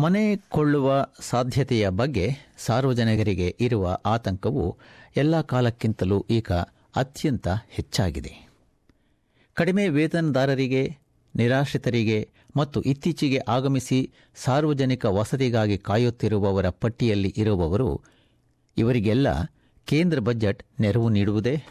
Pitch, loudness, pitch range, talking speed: 120 Hz, -24 LUFS, 110-140 Hz, 75 wpm